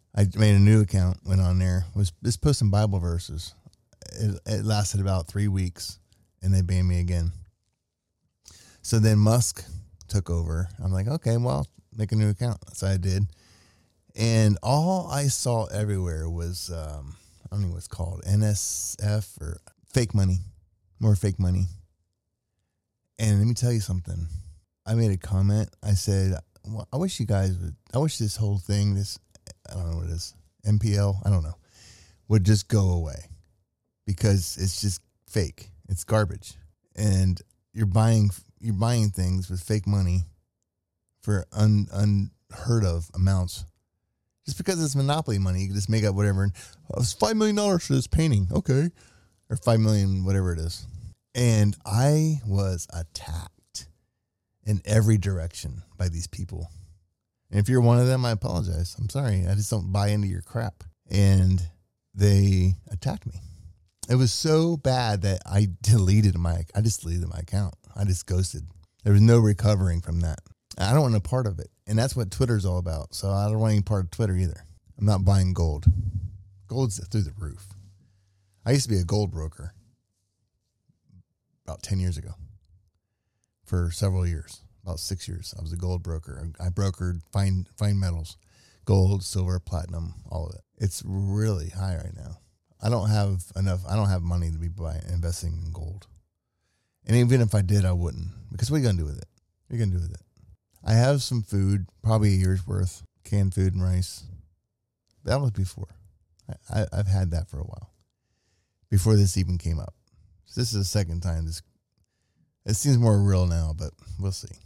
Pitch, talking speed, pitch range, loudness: 95 Hz, 180 wpm, 90-105 Hz, -25 LUFS